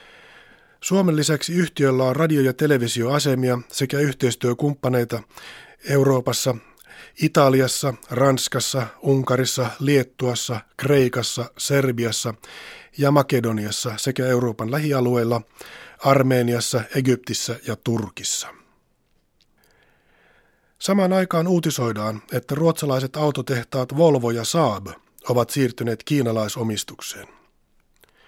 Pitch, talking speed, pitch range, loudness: 130 Hz, 80 wpm, 120-140 Hz, -21 LUFS